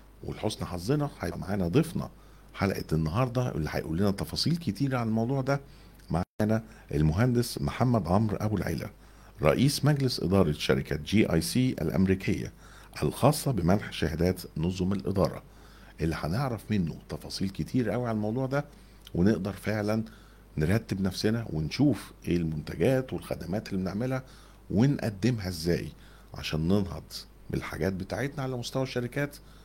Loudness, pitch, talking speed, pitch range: -29 LUFS, 105 Hz, 125 wpm, 85-125 Hz